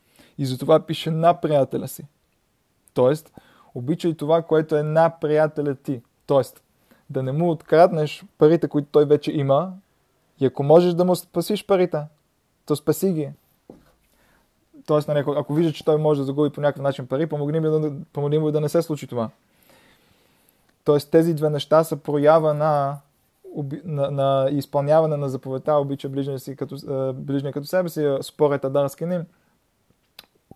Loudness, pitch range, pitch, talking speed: -21 LUFS, 140-160 Hz, 150 Hz, 155 wpm